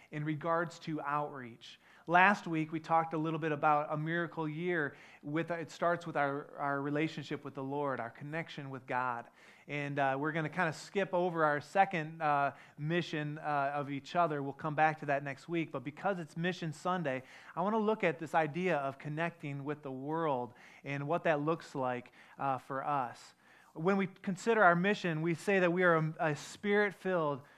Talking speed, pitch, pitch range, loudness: 200 wpm, 155 Hz, 145-170 Hz, -34 LUFS